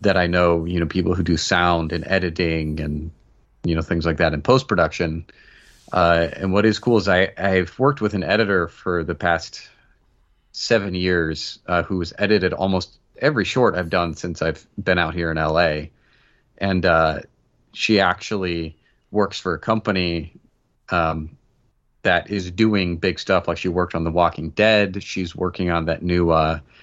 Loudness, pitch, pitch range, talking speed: -20 LUFS, 85 Hz, 80-95 Hz, 180 wpm